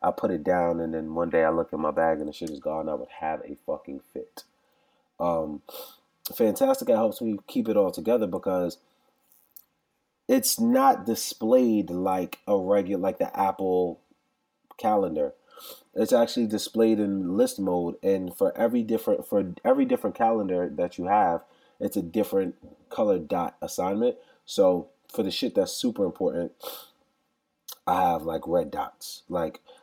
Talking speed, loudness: 160 wpm, -26 LUFS